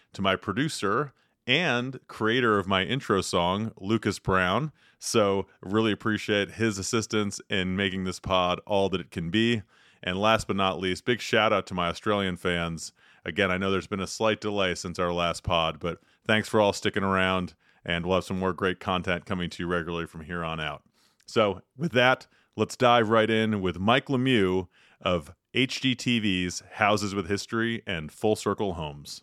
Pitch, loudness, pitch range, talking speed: 95 Hz, -27 LUFS, 90-110 Hz, 185 wpm